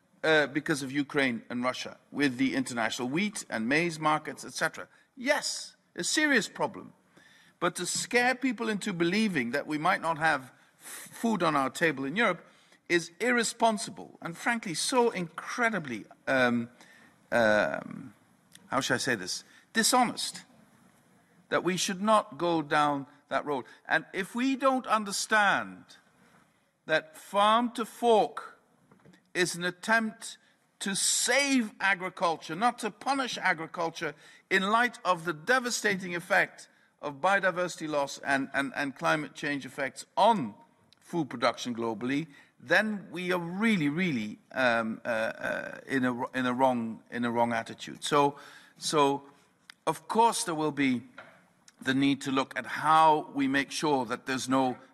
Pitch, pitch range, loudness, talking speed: 170 Hz, 140-215 Hz, -29 LUFS, 145 wpm